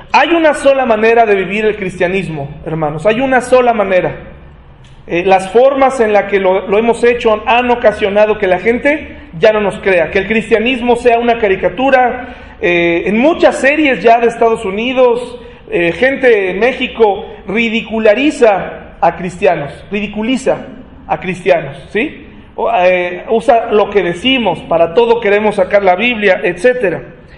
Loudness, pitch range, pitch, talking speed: -12 LUFS, 185-240 Hz, 215 Hz, 155 wpm